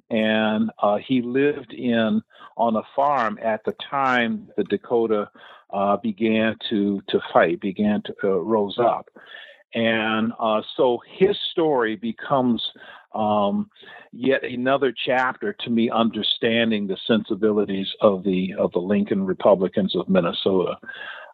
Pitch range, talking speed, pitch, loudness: 105-120 Hz, 130 wpm, 110 Hz, -22 LUFS